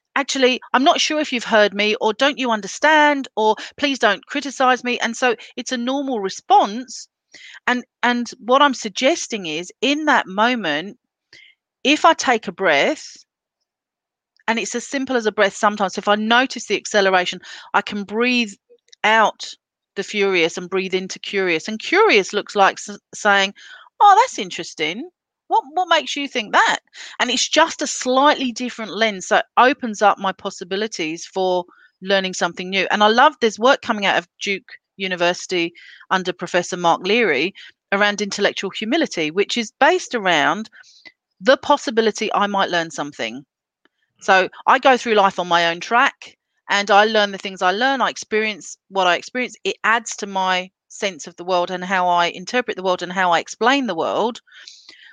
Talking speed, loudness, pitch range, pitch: 175 wpm, -18 LUFS, 190-255 Hz, 215 Hz